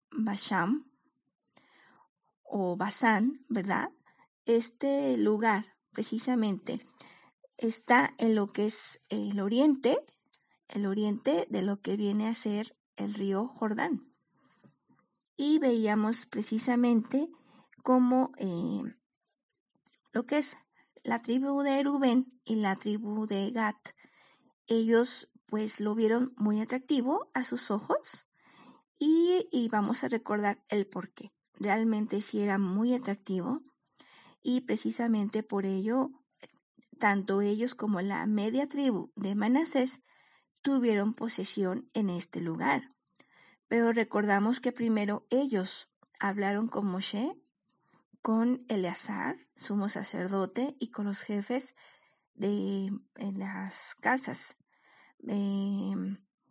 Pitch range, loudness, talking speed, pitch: 205-255 Hz, -31 LUFS, 110 wpm, 225 Hz